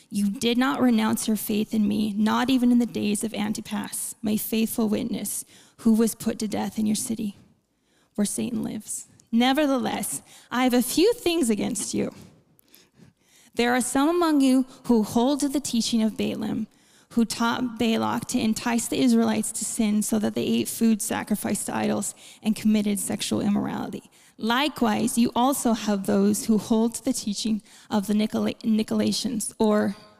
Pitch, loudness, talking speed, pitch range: 225 Hz, -24 LUFS, 170 wpm, 215-240 Hz